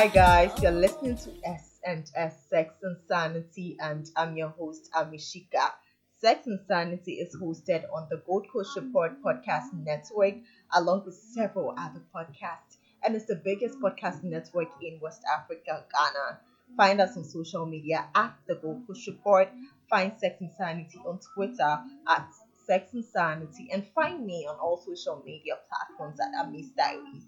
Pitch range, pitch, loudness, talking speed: 165-205 Hz, 180 Hz, -29 LUFS, 145 wpm